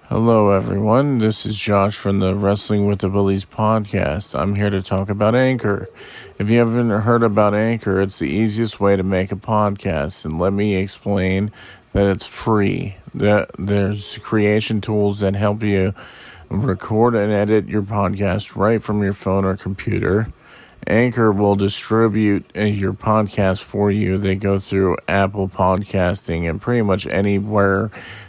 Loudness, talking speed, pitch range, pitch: -18 LUFS, 155 wpm, 95-110 Hz, 100 Hz